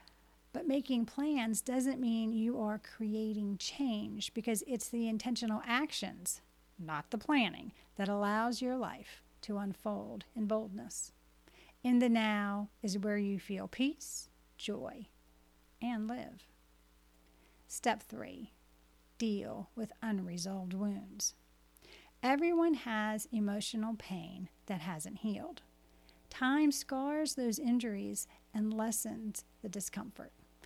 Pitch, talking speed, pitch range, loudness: 215 Hz, 110 wpm, 175-235 Hz, -37 LUFS